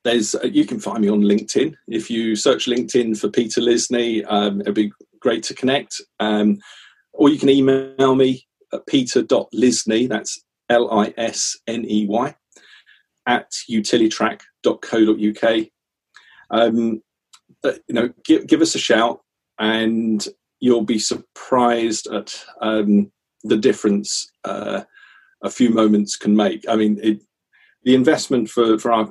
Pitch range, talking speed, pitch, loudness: 105-125 Hz, 130 wpm, 115 Hz, -19 LUFS